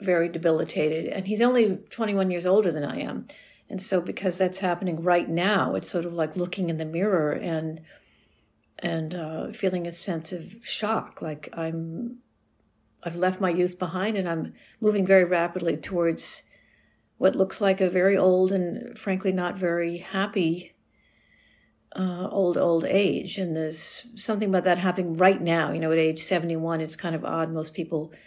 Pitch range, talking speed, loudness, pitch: 165-190 Hz, 170 wpm, -26 LUFS, 180 Hz